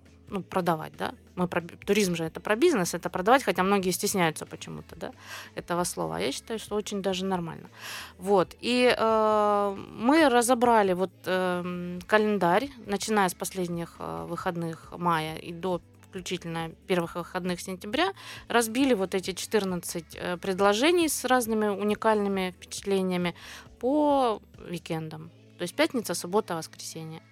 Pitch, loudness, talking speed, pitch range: 185 Hz, -27 LUFS, 130 wpm, 175-215 Hz